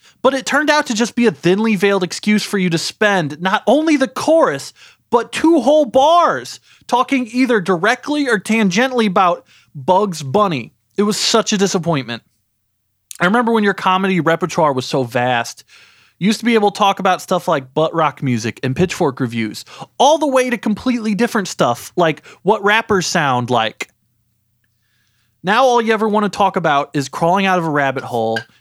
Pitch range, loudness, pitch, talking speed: 140-225 Hz, -16 LUFS, 190 Hz, 185 wpm